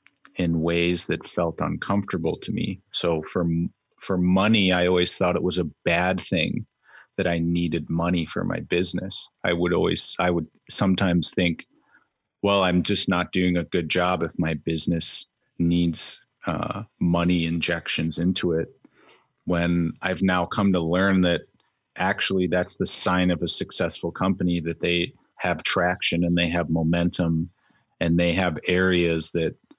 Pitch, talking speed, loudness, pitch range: 85 Hz, 155 wpm, -23 LUFS, 85-90 Hz